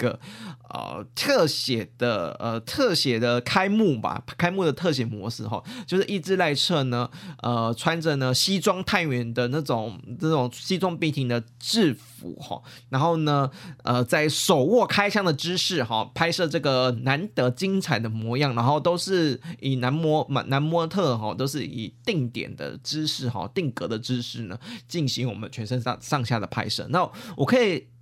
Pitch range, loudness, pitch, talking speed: 120-170 Hz, -25 LUFS, 135 Hz, 245 characters per minute